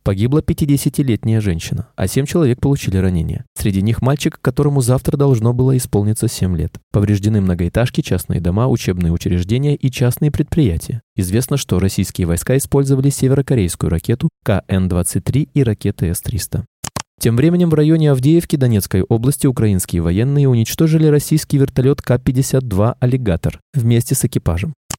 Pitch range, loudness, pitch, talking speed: 100-140 Hz, -16 LUFS, 125 Hz, 130 wpm